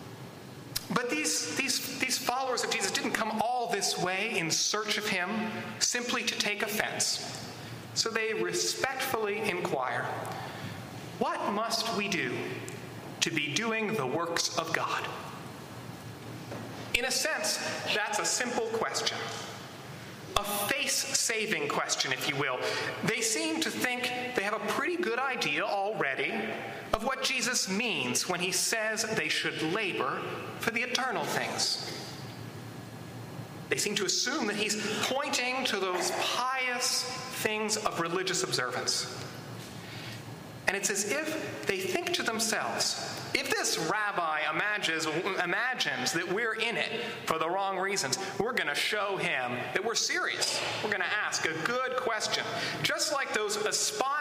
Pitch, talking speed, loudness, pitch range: 220 Hz, 140 wpm, -30 LUFS, 185-255 Hz